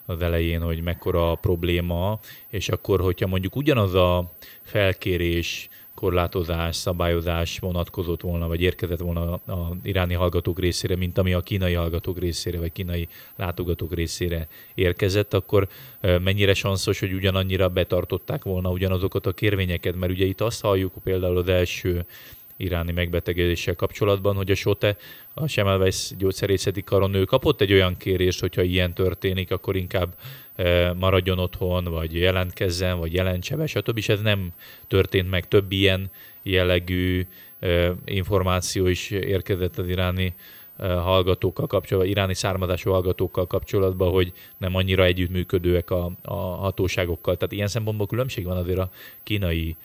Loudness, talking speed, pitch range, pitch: -24 LUFS, 135 wpm, 90-100 Hz, 95 Hz